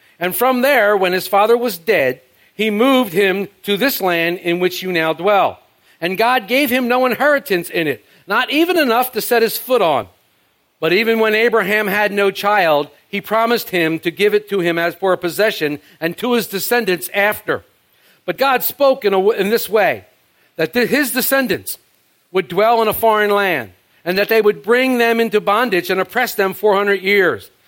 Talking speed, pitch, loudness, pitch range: 195 wpm, 210 Hz, -16 LUFS, 185-235 Hz